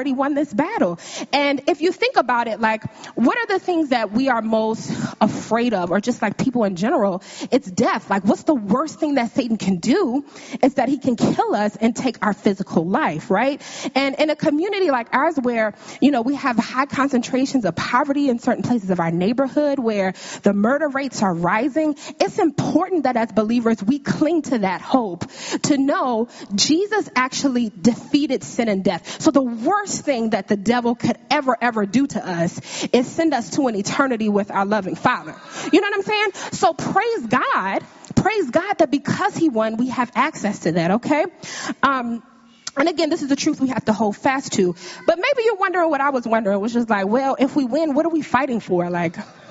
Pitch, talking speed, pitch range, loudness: 255 Hz, 205 wpm, 220-295 Hz, -20 LUFS